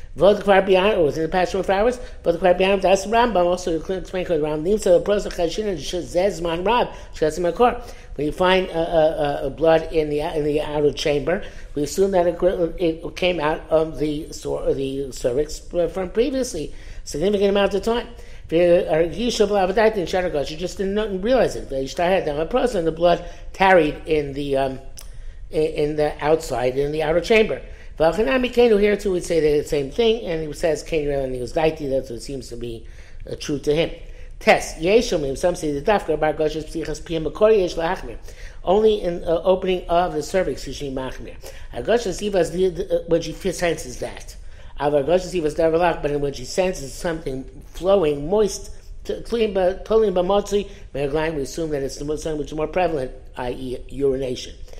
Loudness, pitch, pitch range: -21 LUFS, 165 Hz, 150-190 Hz